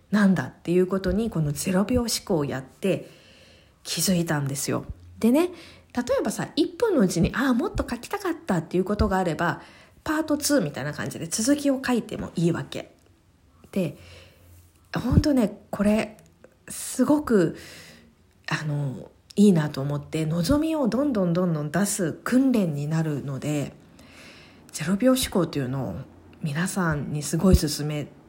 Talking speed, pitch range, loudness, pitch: 295 characters per minute, 145-230 Hz, -25 LUFS, 175 Hz